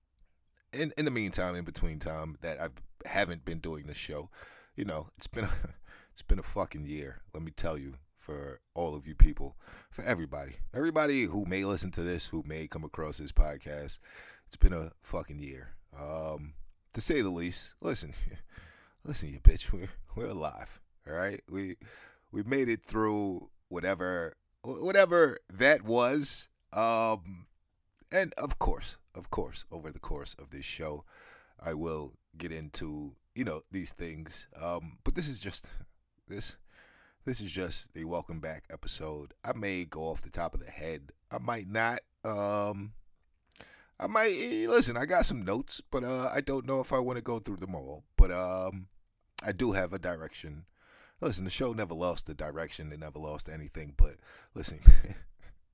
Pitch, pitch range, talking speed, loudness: 85 Hz, 75-105 Hz, 175 wpm, -33 LUFS